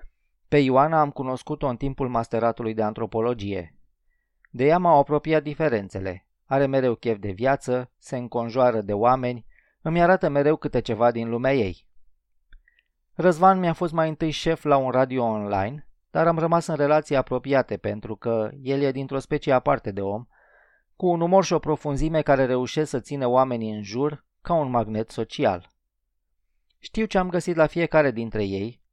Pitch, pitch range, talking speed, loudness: 130 Hz, 115-150 Hz, 170 wpm, -23 LUFS